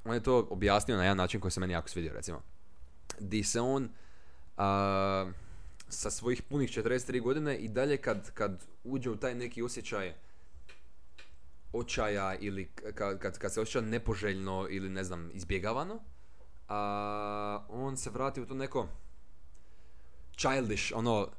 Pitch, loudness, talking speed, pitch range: 100 Hz, -34 LUFS, 145 wpm, 85-120 Hz